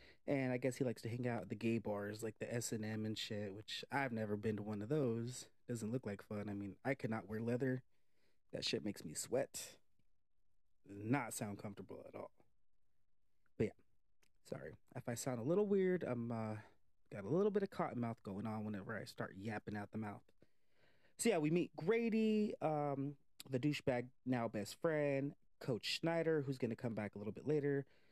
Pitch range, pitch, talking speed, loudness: 110-140 Hz, 120 Hz, 205 wpm, -42 LUFS